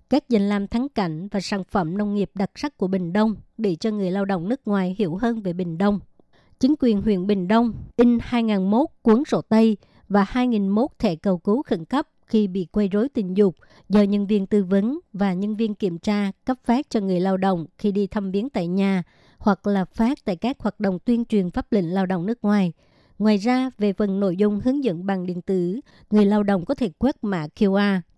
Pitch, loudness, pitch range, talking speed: 205 Hz, -22 LUFS, 195-230 Hz, 225 wpm